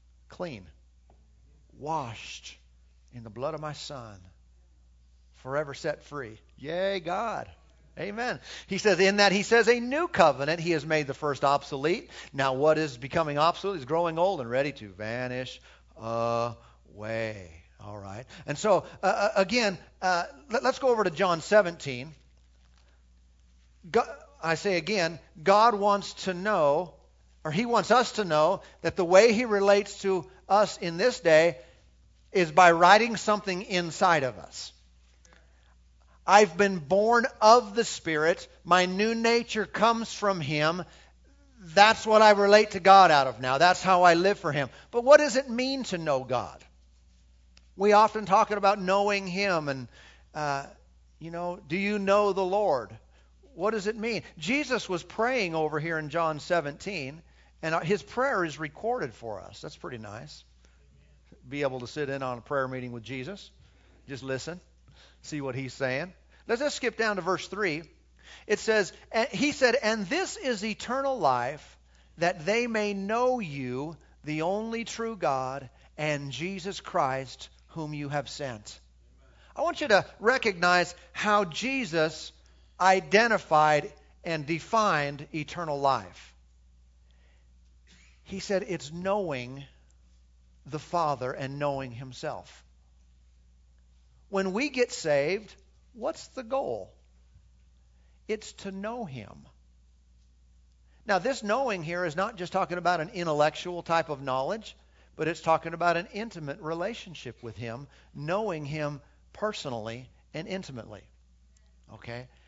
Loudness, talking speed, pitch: -27 LUFS, 145 wpm, 155 Hz